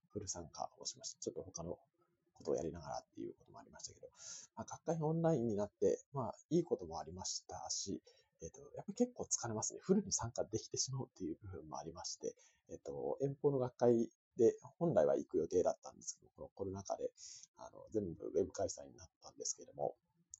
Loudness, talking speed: -40 LUFS, 450 characters per minute